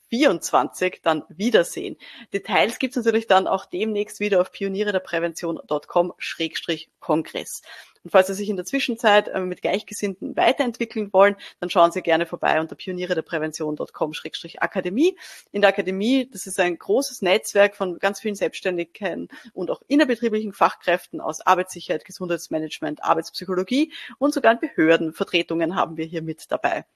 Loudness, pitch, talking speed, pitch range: -22 LUFS, 190 Hz, 140 wpm, 170-215 Hz